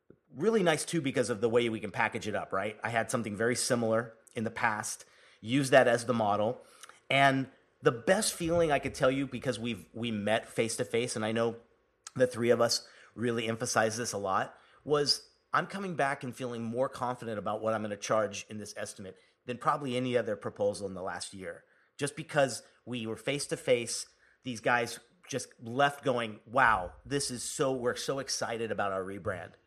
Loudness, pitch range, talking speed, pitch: -31 LUFS, 110-135 Hz, 205 wpm, 120 Hz